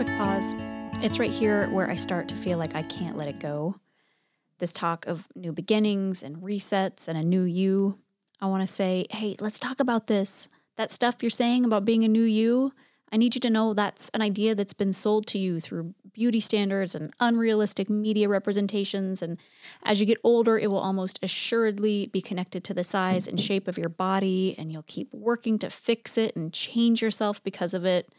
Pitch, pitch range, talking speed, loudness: 200 Hz, 185-220 Hz, 205 wpm, -26 LUFS